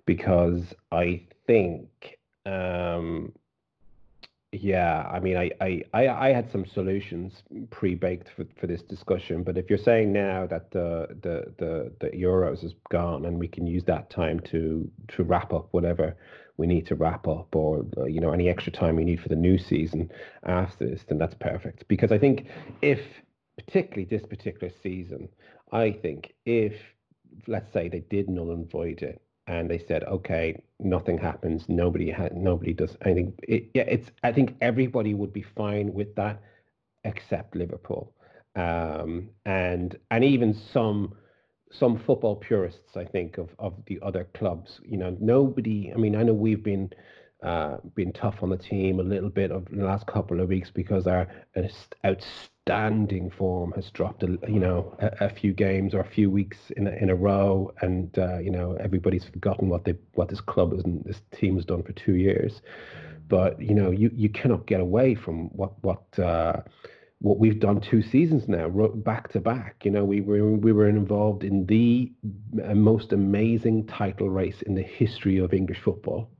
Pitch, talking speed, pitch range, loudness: 95 Hz, 180 wpm, 90-105 Hz, -26 LUFS